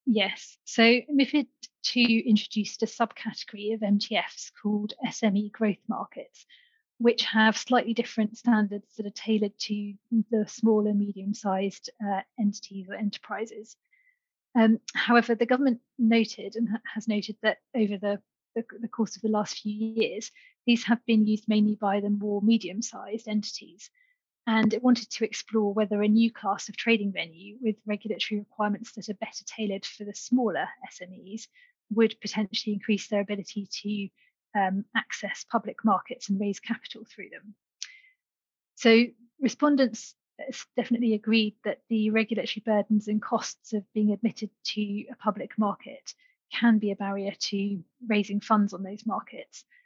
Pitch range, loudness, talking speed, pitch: 210-235 Hz, -27 LUFS, 150 wpm, 220 Hz